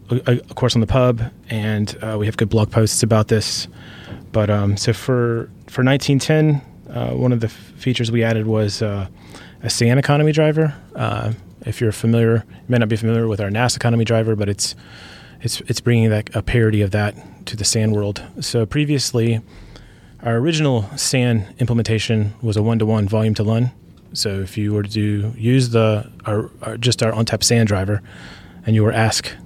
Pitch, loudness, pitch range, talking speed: 110 Hz, -18 LUFS, 105-120 Hz, 195 wpm